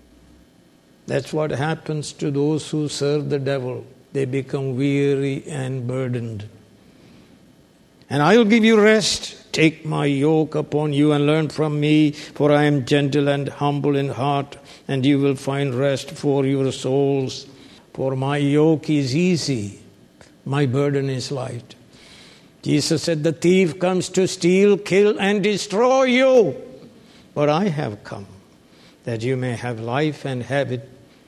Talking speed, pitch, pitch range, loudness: 150 wpm, 145 Hz, 135-155 Hz, -20 LUFS